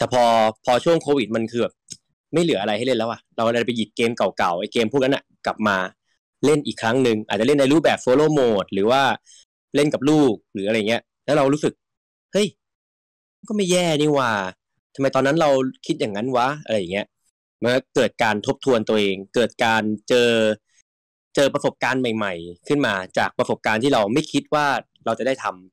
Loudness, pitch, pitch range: -21 LUFS, 120 Hz, 110-145 Hz